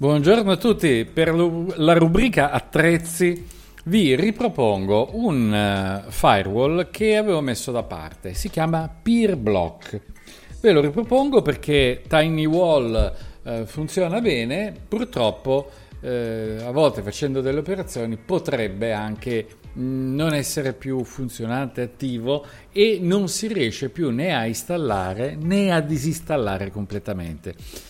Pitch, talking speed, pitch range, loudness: 145 Hz, 110 wpm, 115-175 Hz, -21 LUFS